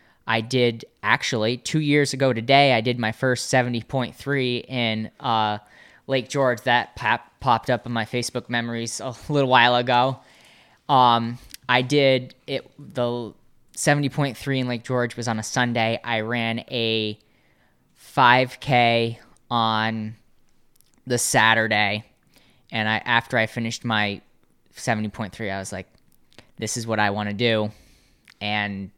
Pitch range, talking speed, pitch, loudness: 110-125 Hz, 145 wpm, 120 Hz, -22 LUFS